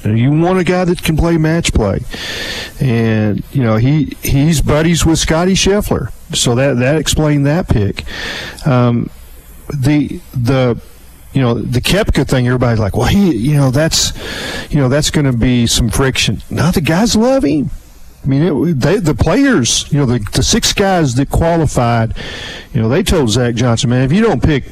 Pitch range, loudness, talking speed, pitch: 120-160 Hz, -13 LUFS, 185 wpm, 135 Hz